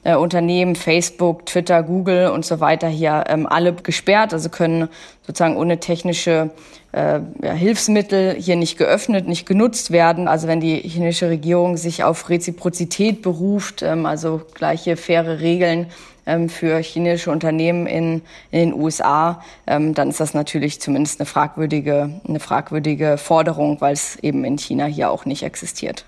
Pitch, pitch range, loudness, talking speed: 170 Hz, 160-175 Hz, -18 LUFS, 155 wpm